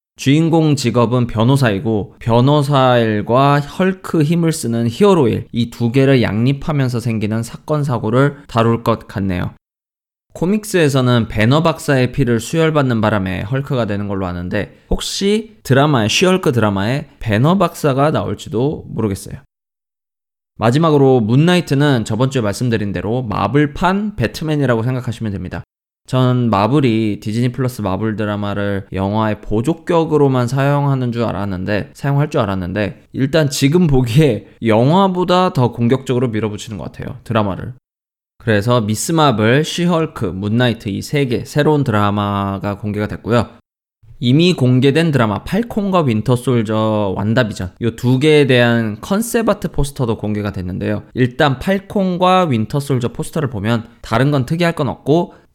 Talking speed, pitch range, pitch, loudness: 340 characters per minute, 110-150 Hz, 125 Hz, -16 LUFS